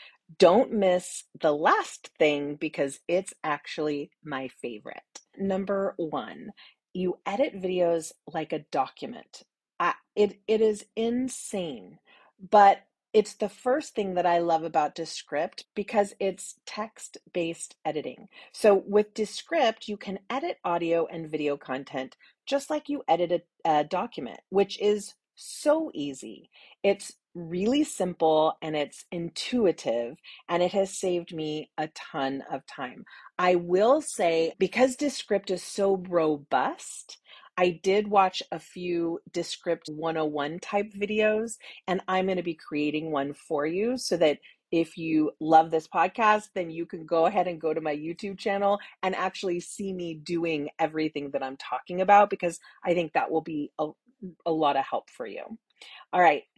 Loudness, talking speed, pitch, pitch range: -27 LUFS, 150 wpm, 180 Hz, 160-205 Hz